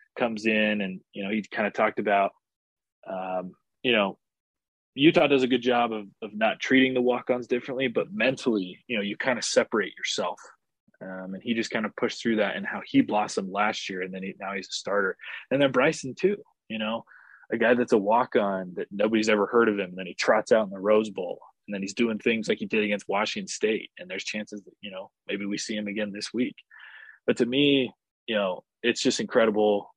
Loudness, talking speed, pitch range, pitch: -26 LUFS, 230 wpm, 100-125 Hz, 105 Hz